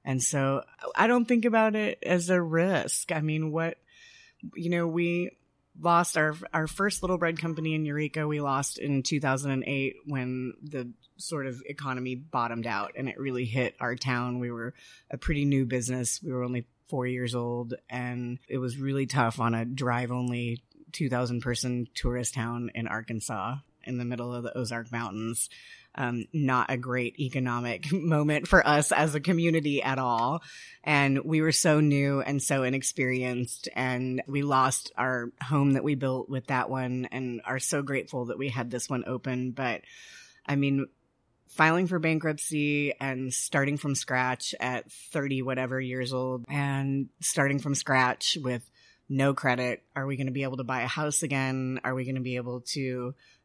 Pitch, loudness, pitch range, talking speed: 135 Hz, -29 LUFS, 125-150 Hz, 175 wpm